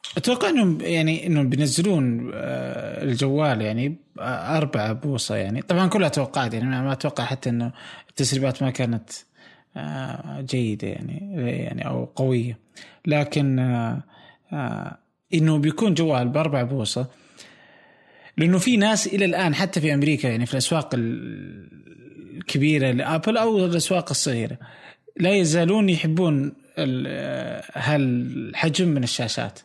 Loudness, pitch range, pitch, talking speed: -23 LUFS, 125-165 Hz, 145 Hz, 105 wpm